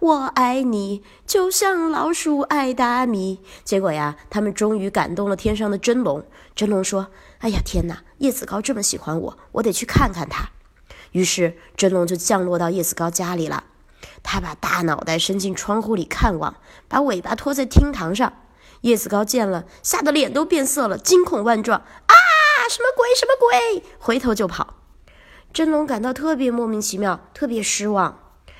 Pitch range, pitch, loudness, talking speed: 195-285 Hz, 225 Hz, -20 LUFS, 255 characters per minute